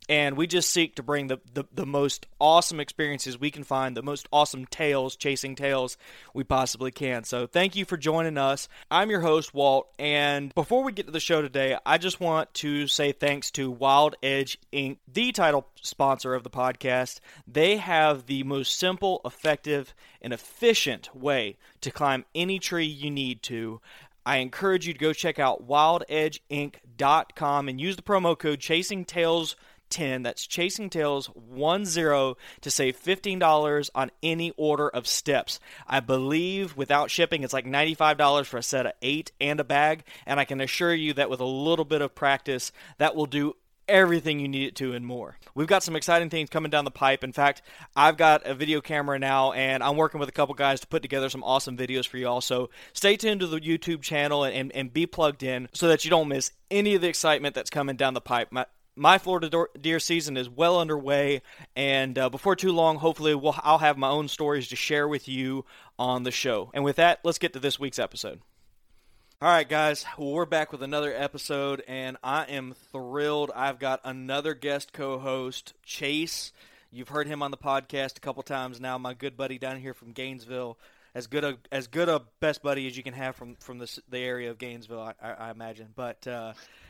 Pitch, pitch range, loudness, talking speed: 140 Hz, 130-155 Hz, -26 LUFS, 205 wpm